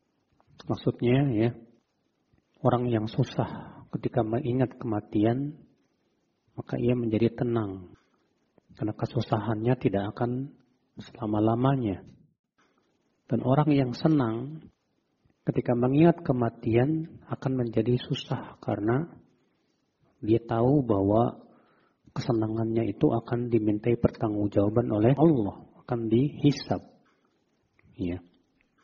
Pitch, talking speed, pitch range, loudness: 120 Hz, 85 wpm, 110-135 Hz, -27 LUFS